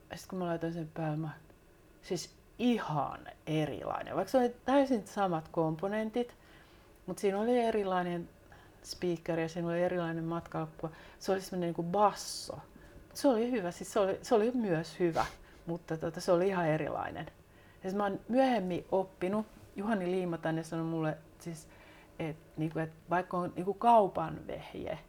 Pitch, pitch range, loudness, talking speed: 180 Hz, 165-205 Hz, -33 LUFS, 160 wpm